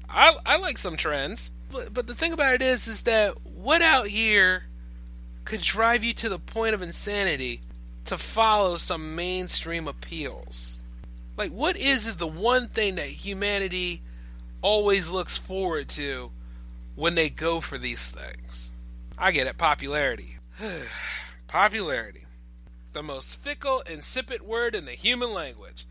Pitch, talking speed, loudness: 175 Hz, 140 wpm, -25 LUFS